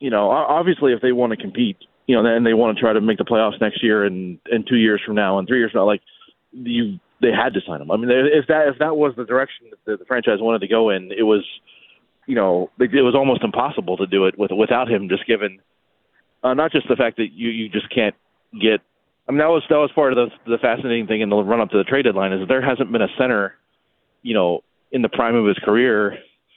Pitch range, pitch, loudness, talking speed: 110-150 Hz, 115 Hz, -19 LUFS, 265 wpm